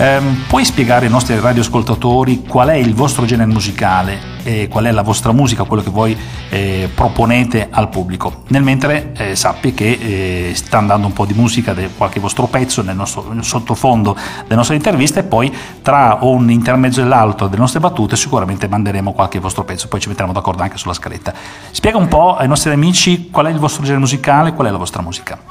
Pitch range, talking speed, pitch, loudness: 100-130 Hz, 195 wpm, 115 Hz, -13 LUFS